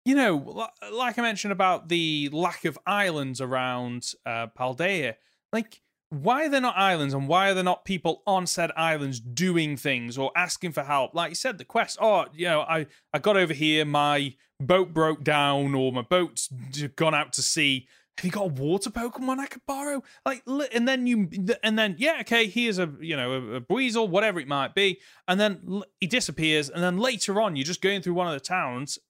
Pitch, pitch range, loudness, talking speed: 180 Hz, 145-215 Hz, -26 LUFS, 210 wpm